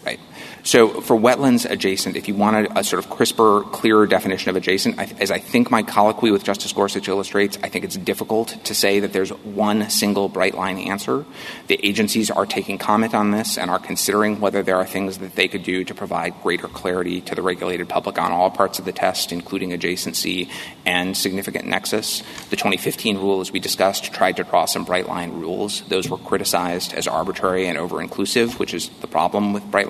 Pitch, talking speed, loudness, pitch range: 100 Hz, 205 wpm, -20 LUFS, 95-105 Hz